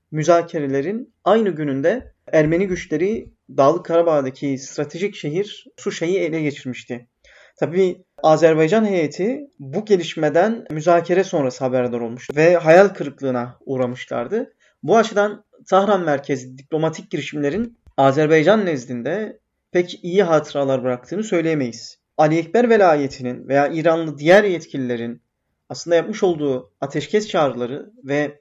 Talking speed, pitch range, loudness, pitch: 110 wpm, 135-190 Hz, -19 LUFS, 160 Hz